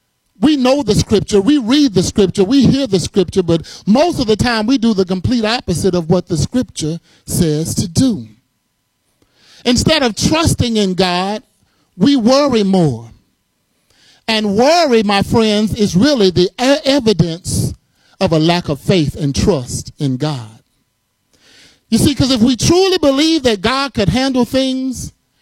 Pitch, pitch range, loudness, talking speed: 210 Hz, 180-260 Hz, -14 LUFS, 155 wpm